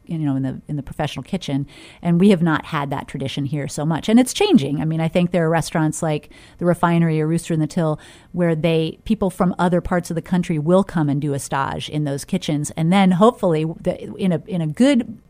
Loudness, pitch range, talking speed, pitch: -20 LUFS, 150-180 Hz, 245 wpm, 165 Hz